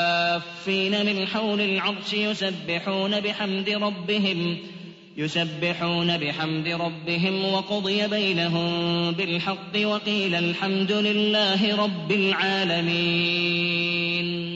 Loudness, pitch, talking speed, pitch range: -23 LUFS, 190 Hz, 70 wpm, 170-205 Hz